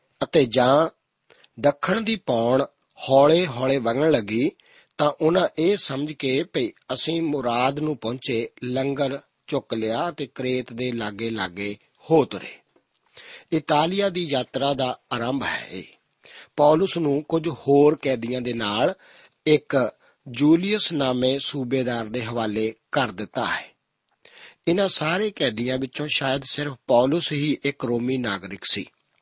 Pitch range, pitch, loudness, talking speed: 125-155 Hz, 135 Hz, -23 LUFS, 125 wpm